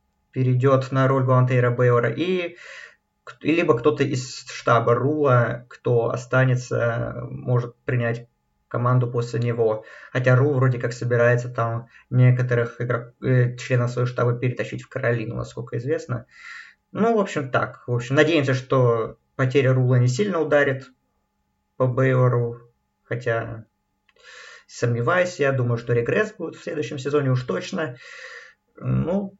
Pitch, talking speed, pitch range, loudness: 125 Hz, 130 wpm, 120-135 Hz, -22 LUFS